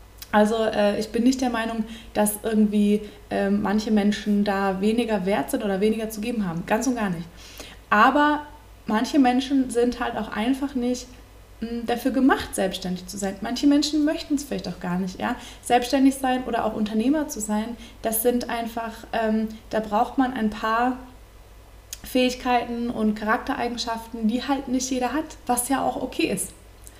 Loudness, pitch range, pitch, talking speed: -24 LUFS, 210-255 Hz, 230 Hz, 160 wpm